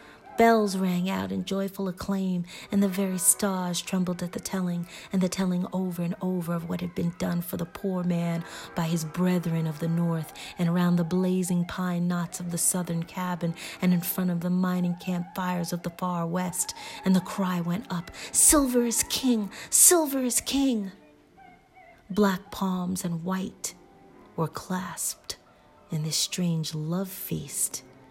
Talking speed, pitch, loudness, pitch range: 170 wpm, 180 Hz, -26 LUFS, 175-195 Hz